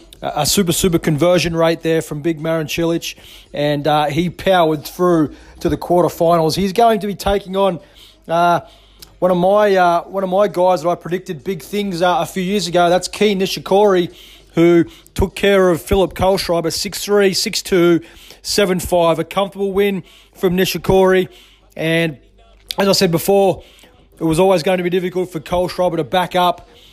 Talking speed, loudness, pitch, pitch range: 170 wpm, -16 LUFS, 180 Hz, 165-190 Hz